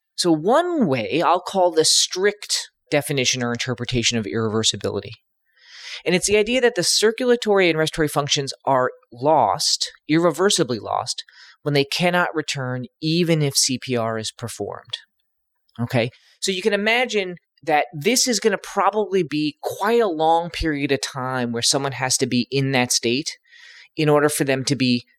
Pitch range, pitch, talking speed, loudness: 125-195 Hz, 150 Hz, 160 wpm, -20 LUFS